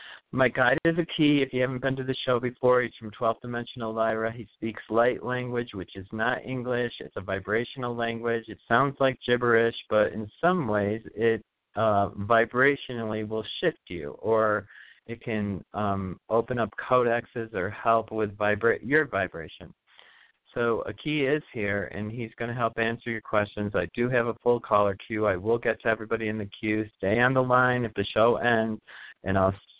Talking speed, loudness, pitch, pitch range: 190 wpm, -27 LUFS, 115 Hz, 105-120 Hz